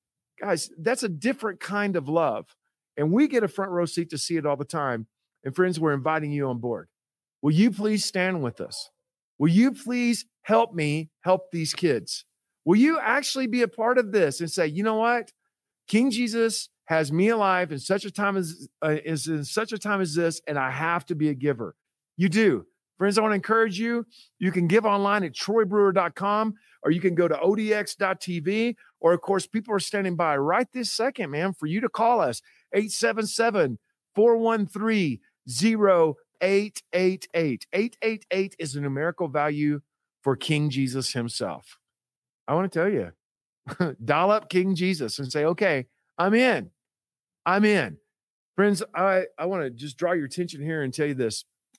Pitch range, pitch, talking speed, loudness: 155-220 Hz, 185 Hz, 180 wpm, -25 LUFS